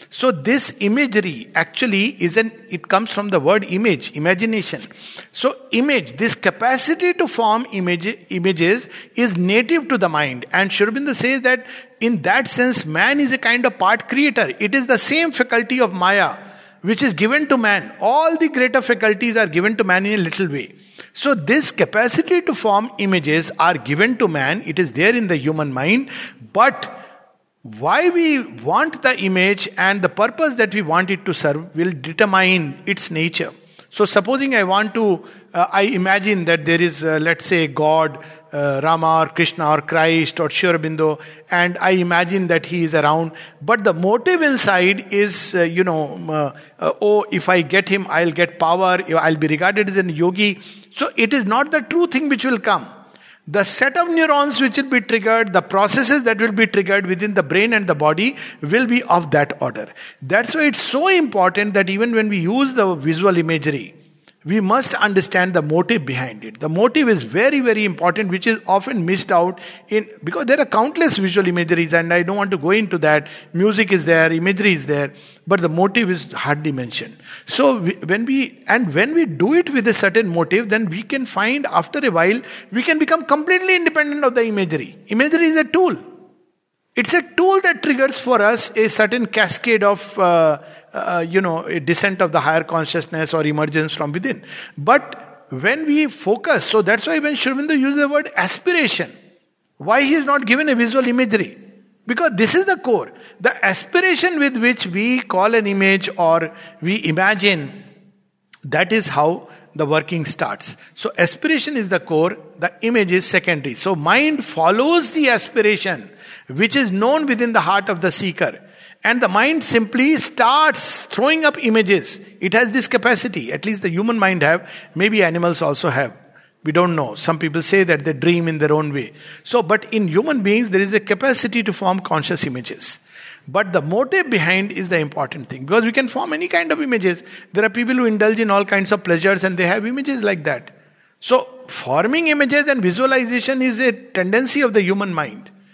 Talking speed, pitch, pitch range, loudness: 190 wpm, 205 Hz, 175-250 Hz, -17 LUFS